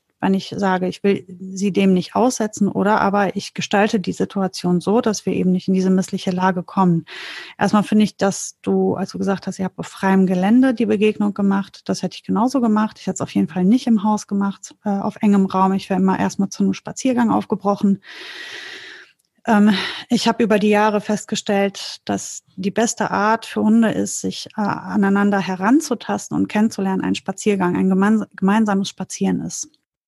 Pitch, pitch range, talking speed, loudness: 200 Hz, 190-215 Hz, 185 wpm, -19 LUFS